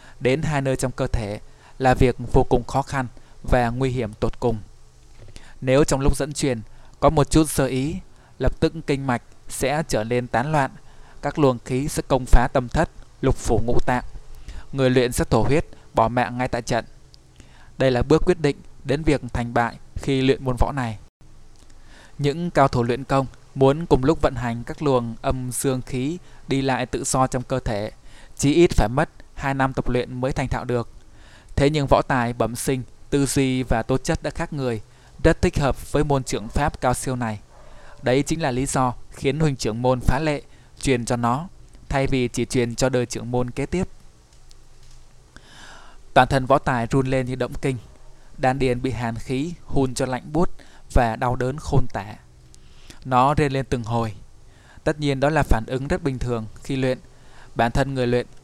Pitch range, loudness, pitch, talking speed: 120-140 Hz, -23 LUFS, 130 Hz, 205 wpm